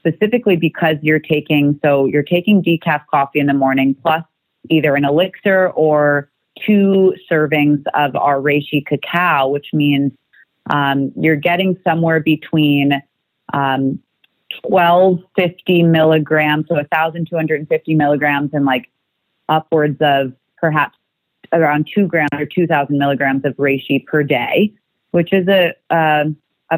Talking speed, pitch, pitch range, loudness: 135 wpm, 155 Hz, 145-170 Hz, -15 LUFS